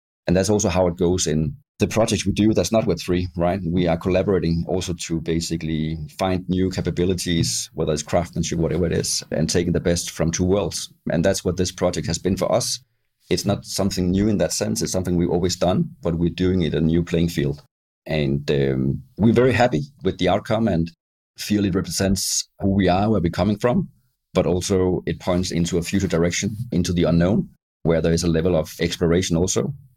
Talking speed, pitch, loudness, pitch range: 210 wpm, 90 Hz, -21 LUFS, 85-100 Hz